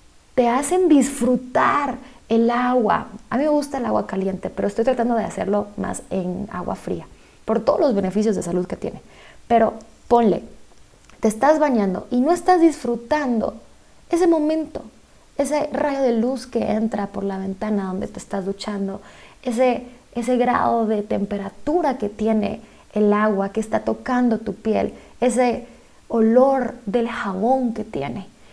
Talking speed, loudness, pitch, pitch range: 155 wpm, -21 LUFS, 235 Hz, 205-260 Hz